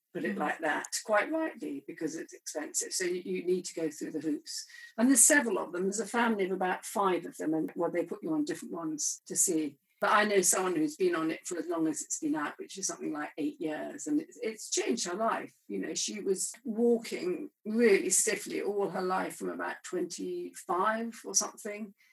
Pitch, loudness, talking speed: 235 Hz, -31 LUFS, 220 wpm